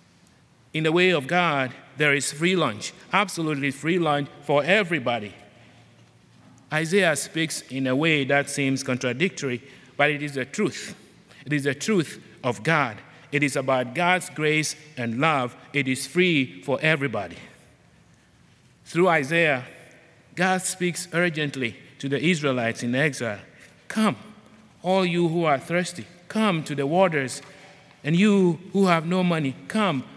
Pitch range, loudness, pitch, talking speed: 135-175 Hz, -24 LUFS, 150 Hz, 145 wpm